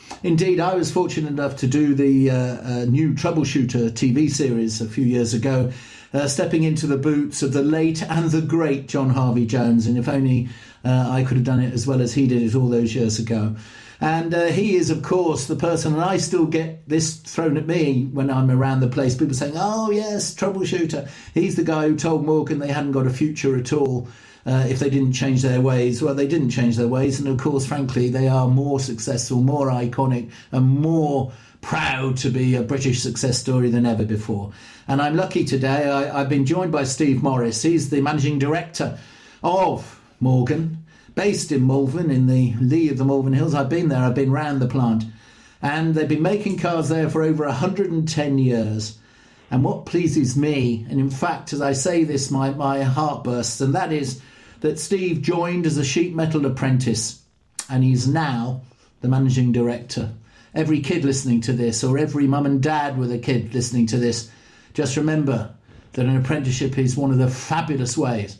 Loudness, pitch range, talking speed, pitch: -21 LUFS, 125-155 Hz, 200 wpm, 135 Hz